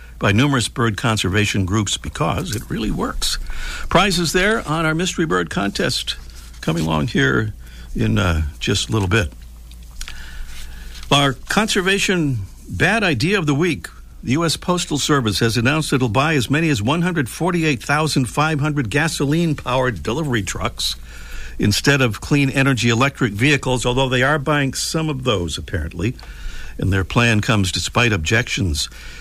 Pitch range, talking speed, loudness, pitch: 90-150 Hz, 140 wpm, -18 LUFS, 120 Hz